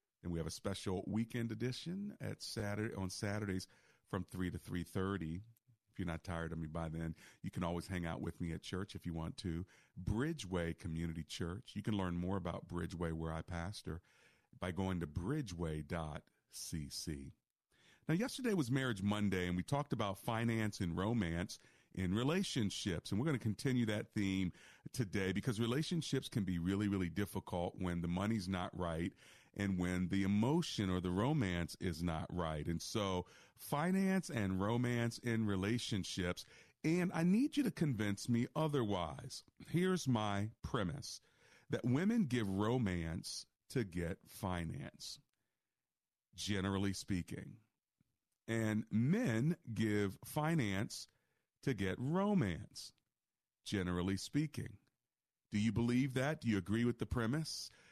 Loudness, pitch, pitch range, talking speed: -40 LUFS, 100 Hz, 90-125 Hz, 145 wpm